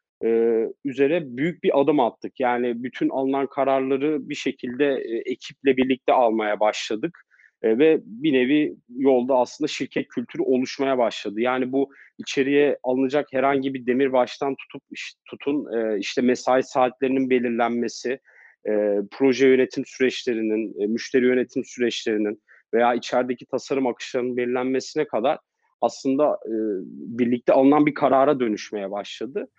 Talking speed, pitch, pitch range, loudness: 130 wpm, 130 Hz, 120-140 Hz, -23 LUFS